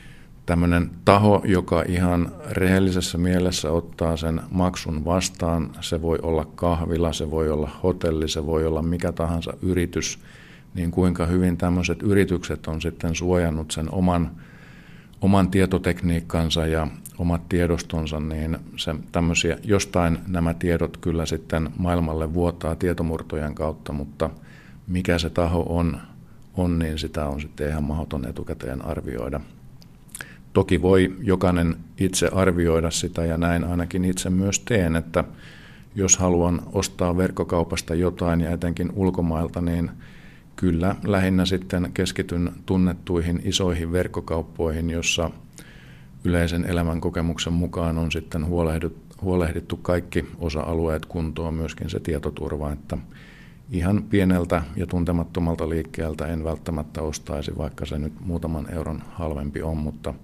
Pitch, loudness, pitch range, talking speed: 85 Hz, -24 LUFS, 80-90 Hz, 125 wpm